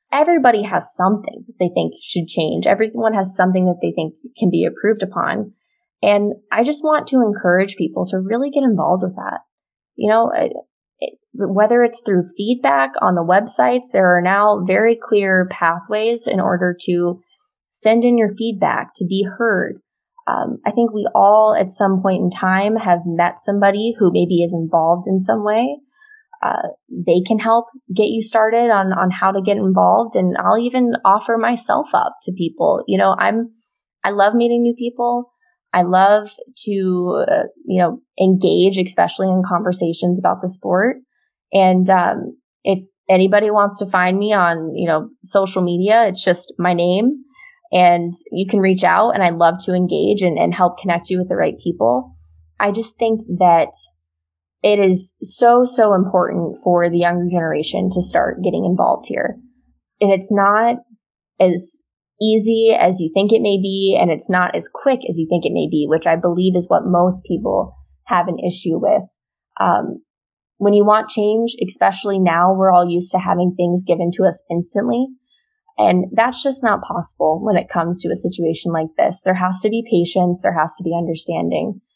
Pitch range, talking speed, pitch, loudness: 180-225 Hz, 180 wpm, 195 Hz, -16 LUFS